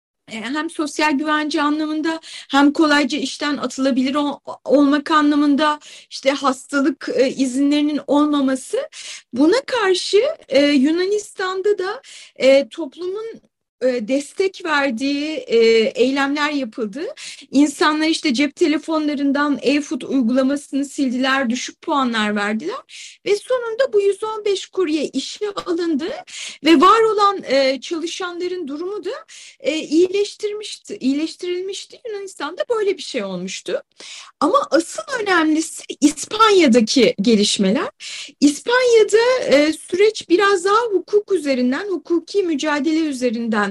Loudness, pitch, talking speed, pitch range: -18 LUFS, 305 Hz, 105 wpm, 275-380 Hz